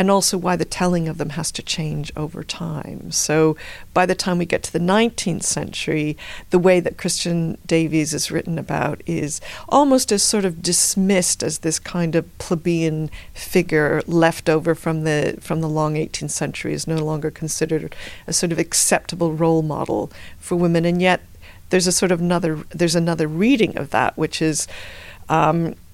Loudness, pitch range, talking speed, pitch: -20 LUFS, 155-180 Hz, 180 wpm, 165 Hz